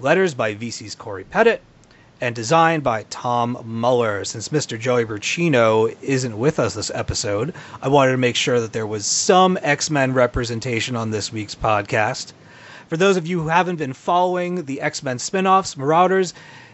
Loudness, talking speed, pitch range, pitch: -20 LUFS, 170 wpm, 115-165 Hz, 130 Hz